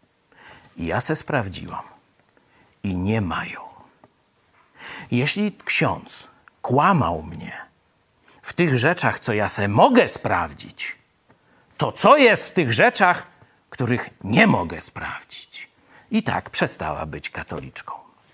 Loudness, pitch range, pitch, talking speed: -21 LUFS, 100-155 Hz, 120 Hz, 110 wpm